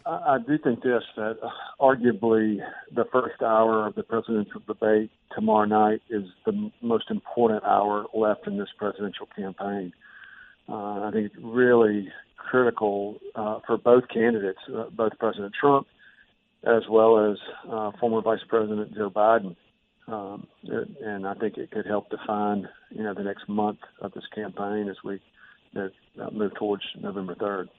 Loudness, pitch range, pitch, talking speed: -26 LUFS, 105-115 Hz, 110 Hz, 155 wpm